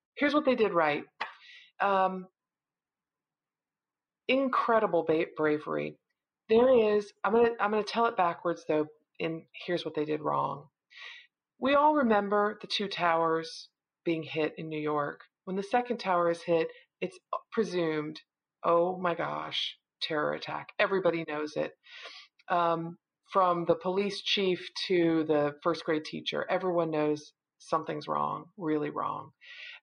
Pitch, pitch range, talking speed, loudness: 175 Hz, 160-210 Hz, 135 wpm, -30 LUFS